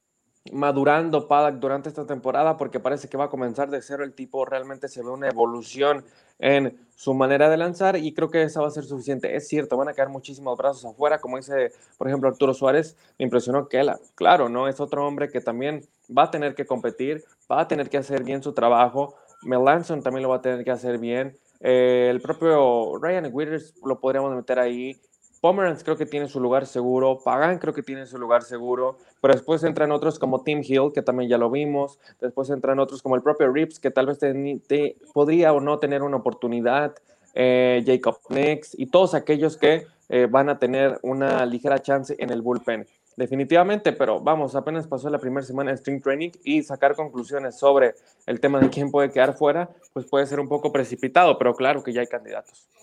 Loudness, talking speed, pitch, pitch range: -23 LUFS, 210 wpm, 140 Hz, 130-150 Hz